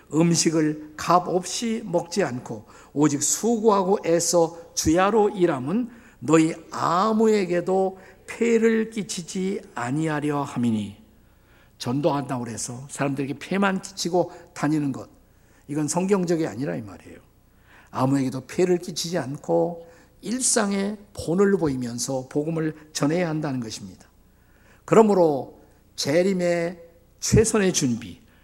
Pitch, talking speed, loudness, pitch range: 165 Hz, 260 characters per minute, -23 LUFS, 140-190 Hz